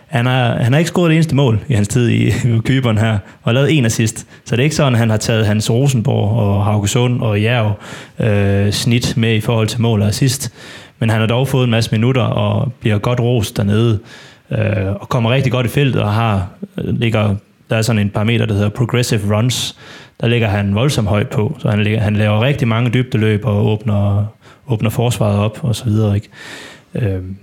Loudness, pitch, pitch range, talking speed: -15 LUFS, 115 Hz, 105-125 Hz, 215 wpm